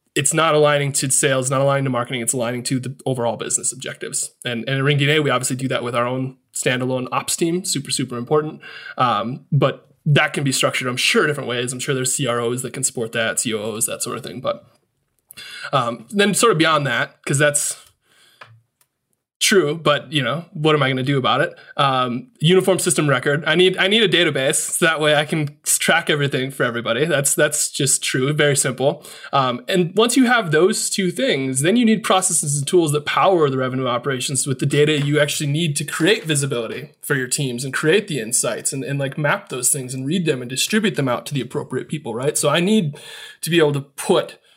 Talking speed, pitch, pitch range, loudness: 220 wpm, 145 Hz, 130-155 Hz, -19 LUFS